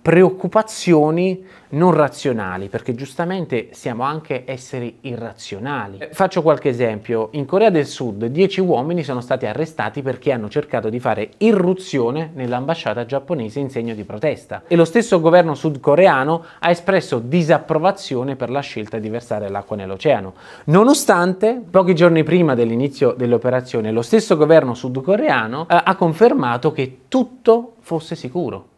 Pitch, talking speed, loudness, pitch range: 150 Hz, 135 wpm, -18 LUFS, 125-180 Hz